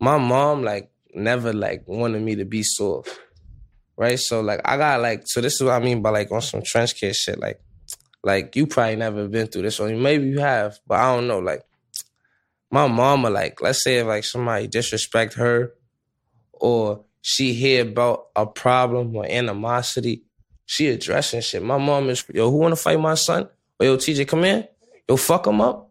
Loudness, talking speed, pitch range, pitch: -21 LUFS, 195 wpm, 110-130 Hz, 120 Hz